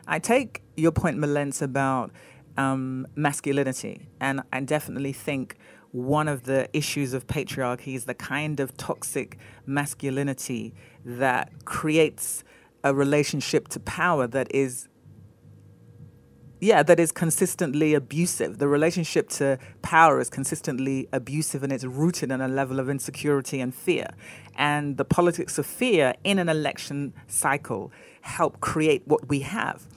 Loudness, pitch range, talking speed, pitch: -25 LUFS, 130-150 Hz, 135 wpm, 140 Hz